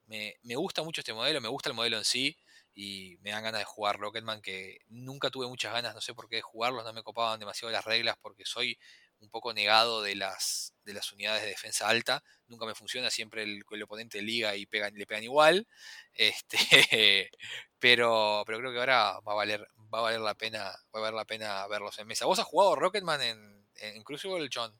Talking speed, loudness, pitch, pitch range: 225 wpm, -29 LUFS, 110 Hz, 105-120 Hz